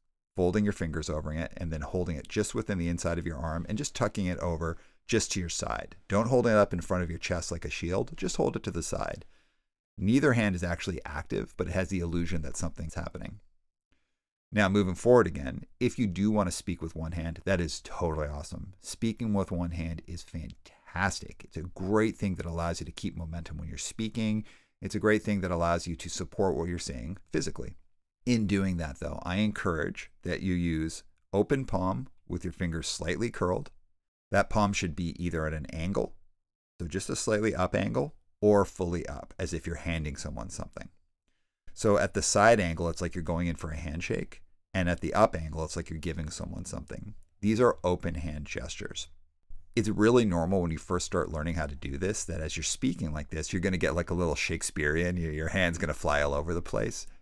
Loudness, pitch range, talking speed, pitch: -31 LUFS, 80-95 Hz, 215 wpm, 85 Hz